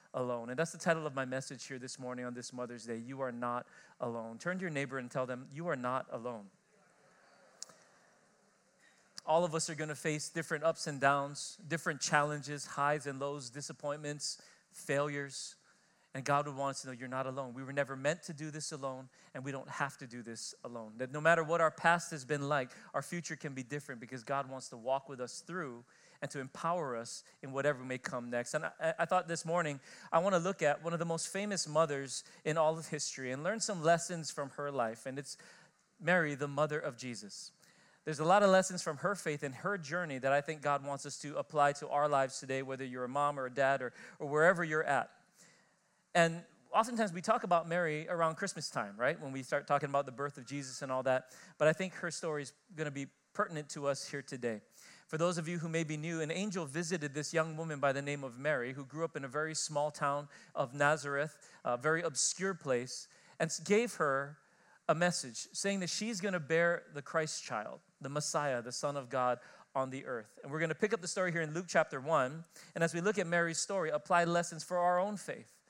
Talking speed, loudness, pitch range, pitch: 230 wpm, -36 LUFS, 135-170 Hz, 150 Hz